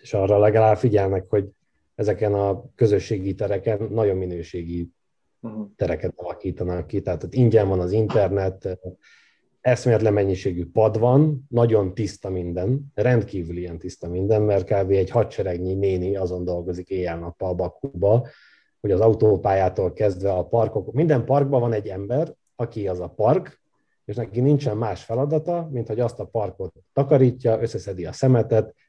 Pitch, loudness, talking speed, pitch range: 105 Hz, -22 LUFS, 145 wpm, 95-115 Hz